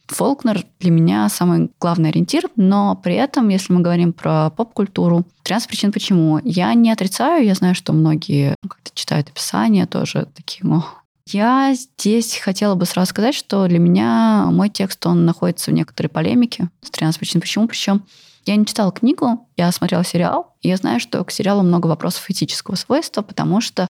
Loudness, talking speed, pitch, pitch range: -17 LUFS, 175 wpm, 190 Hz, 170-220 Hz